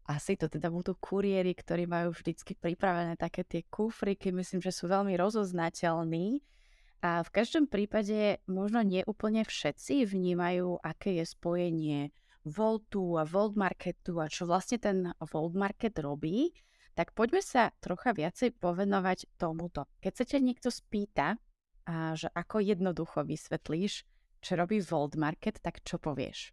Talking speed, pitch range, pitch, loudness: 145 wpm, 170-210 Hz, 180 Hz, -33 LUFS